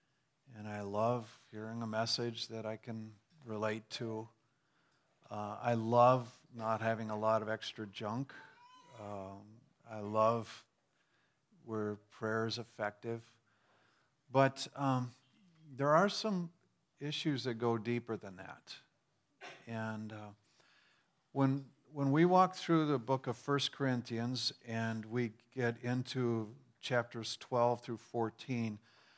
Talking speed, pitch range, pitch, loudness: 120 wpm, 110-140 Hz, 120 Hz, -36 LUFS